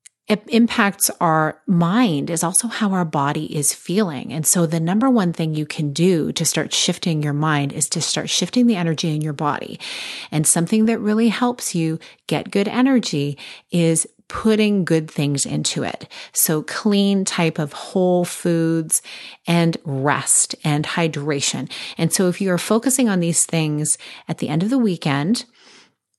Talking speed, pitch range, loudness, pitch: 170 wpm, 155-205 Hz, -19 LUFS, 170 Hz